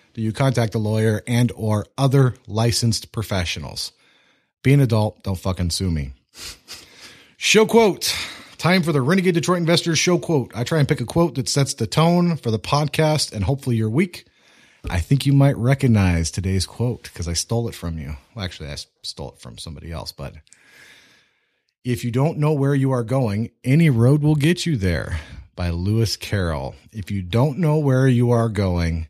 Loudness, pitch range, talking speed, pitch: -20 LUFS, 95-140 Hz, 185 wpm, 115 Hz